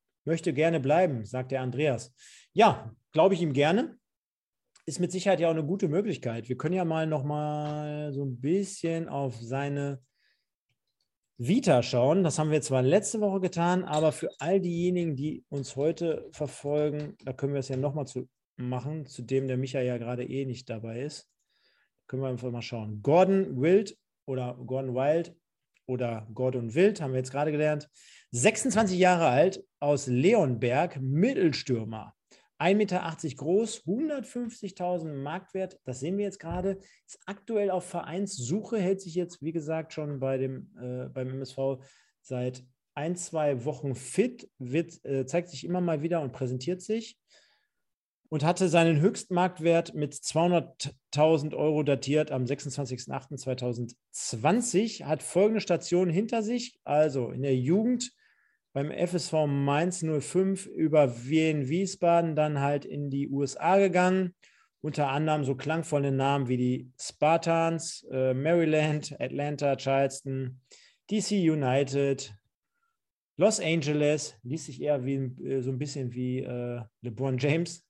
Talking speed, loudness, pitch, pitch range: 145 wpm, -29 LUFS, 150 Hz, 135-180 Hz